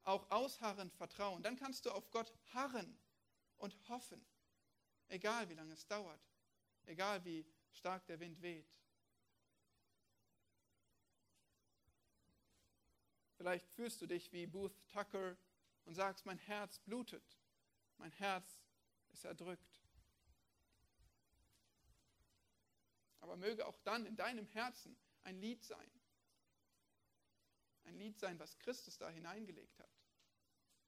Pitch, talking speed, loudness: 150 Hz, 110 wpm, -48 LUFS